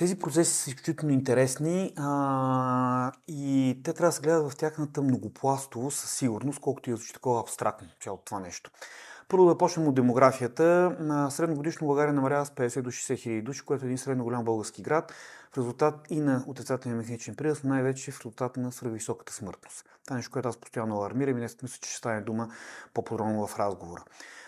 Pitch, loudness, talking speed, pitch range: 130 Hz, -29 LUFS, 185 wpm, 120-150 Hz